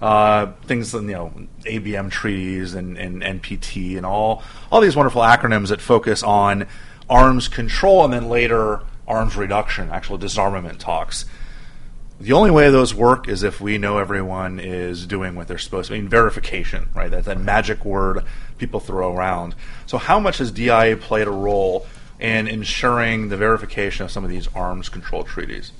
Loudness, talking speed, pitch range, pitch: -19 LUFS, 170 wpm, 95-115 Hz, 105 Hz